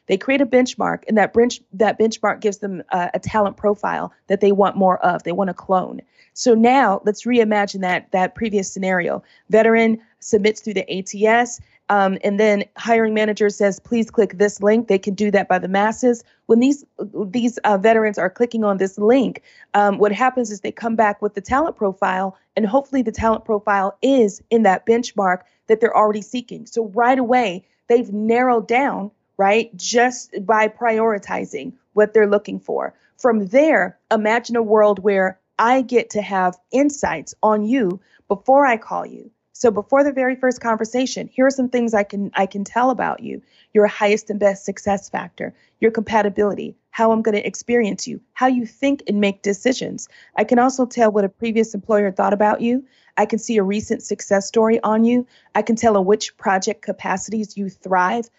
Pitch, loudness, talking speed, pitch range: 215 Hz, -18 LUFS, 190 wpm, 200-235 Hz